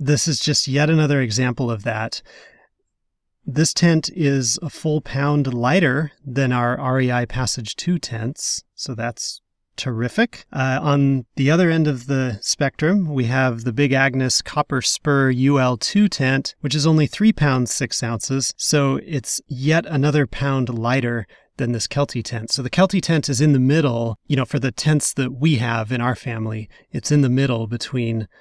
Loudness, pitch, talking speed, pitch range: -20 LUFS, 135 Hz, 175 wpm, 125-150 Hz